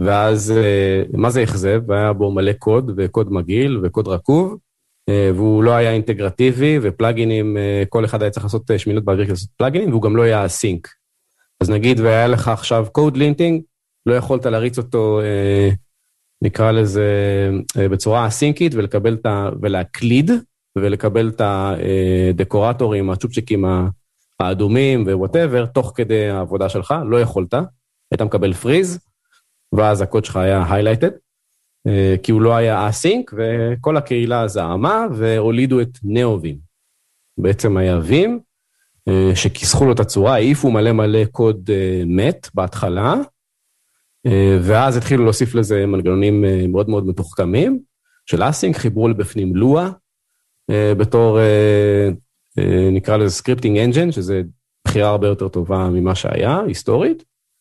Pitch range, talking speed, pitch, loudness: 100-120 Hz, 125 wpm, 110 Hz, -16 LUFS